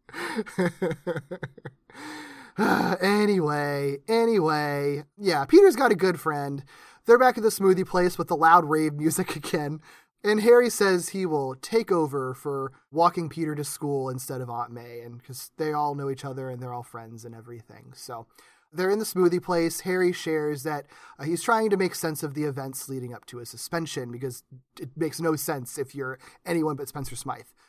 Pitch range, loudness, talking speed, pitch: 135-185 Hz, -25 LUFS, 180 wpm, 155 Hz